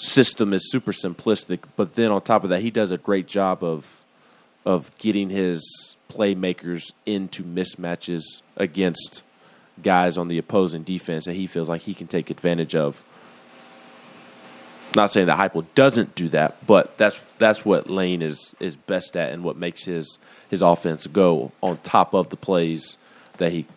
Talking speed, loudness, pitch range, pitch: 175 wpm, -22 LUFS, 85-100 Hz, 90 Hz